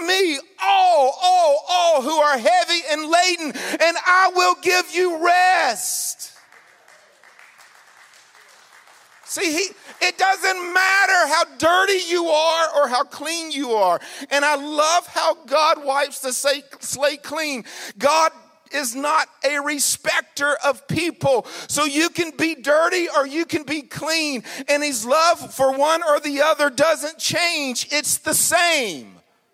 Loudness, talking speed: -19 LUFS, 135 wpm